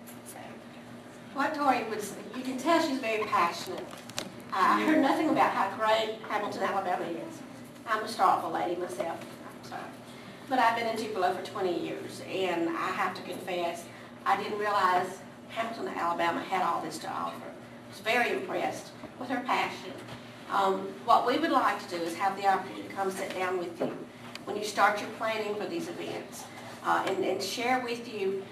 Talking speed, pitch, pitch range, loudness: 185 wpm, 205 Hz, 190-230 Hz, -30 LUFS